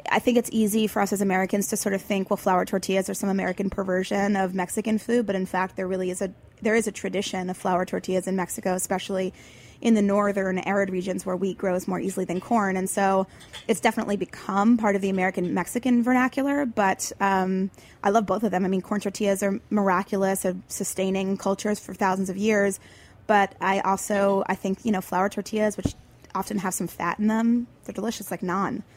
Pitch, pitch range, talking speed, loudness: 195 Hz, 185-210 Hz, 210 wpm, -25 LUFS